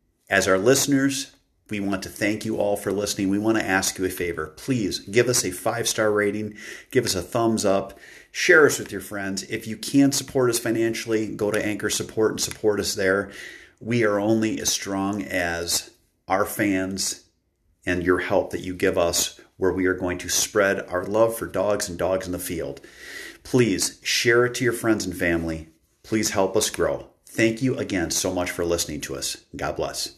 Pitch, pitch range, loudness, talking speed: 100 Hz, 90-110 Hz, -23 LUFS, 205 wpm